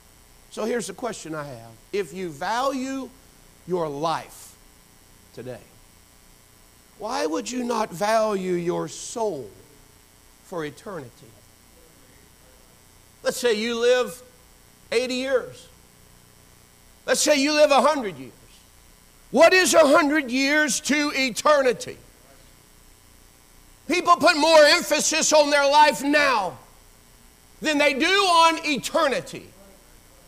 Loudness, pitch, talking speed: -21 LUFS, 235 Hz, 105 wpm